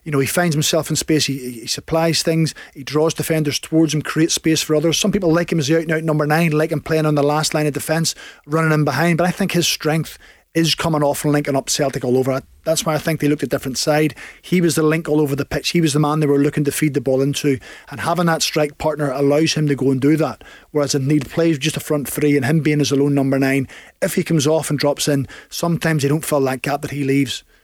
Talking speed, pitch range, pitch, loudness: 280 wpm, 145-160 Hz, 150 Hz, -18 LUFS